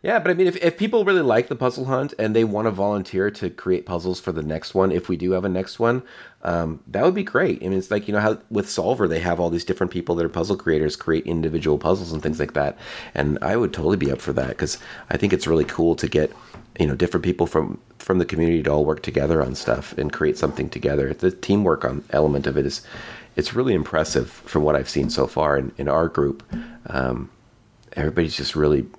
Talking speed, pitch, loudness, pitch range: 245 wpm, 85 Hz, -22 LUFS, 75-100 Hz